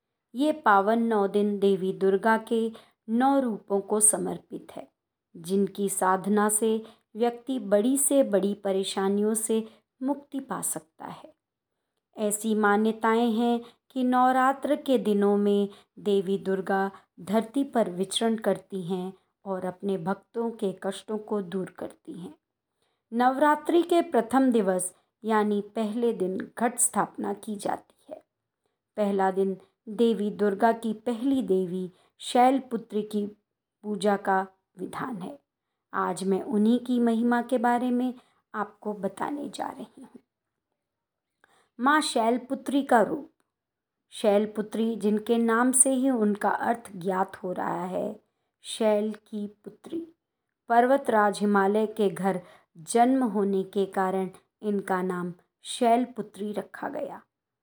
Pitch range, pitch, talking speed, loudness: 195-235 Hz, 215 Hz, 125 wpm, -26 LUFS